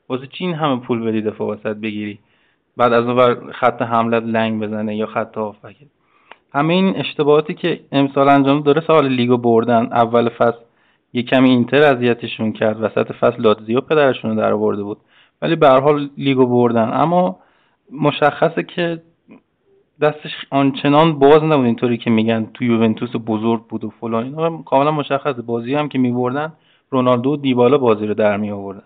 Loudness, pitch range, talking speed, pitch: -16 LUFS, 115-145 Hz, 160 wpm, 125 Hz